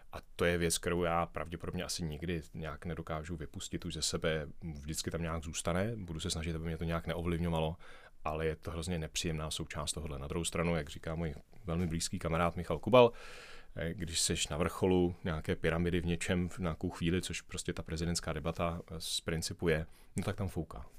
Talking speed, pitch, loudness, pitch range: 195 wpm, 85 Hz, -35 LUFS, 80-85 Hz